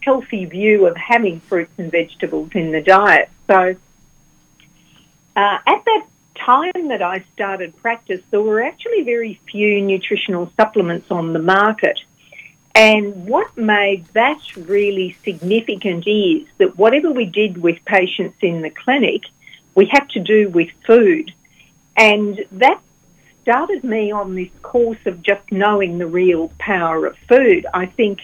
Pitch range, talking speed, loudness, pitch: 180-225 Hz, 145 wpm, -16 LUFS, 200 Hz